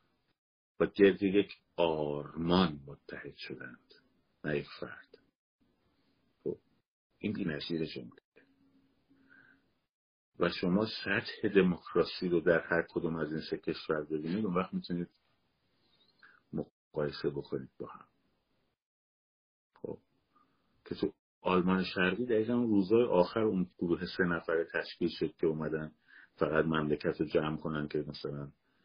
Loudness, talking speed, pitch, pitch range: -33 LUFS, 115 wpm, 80 Hz, 75-95 Hz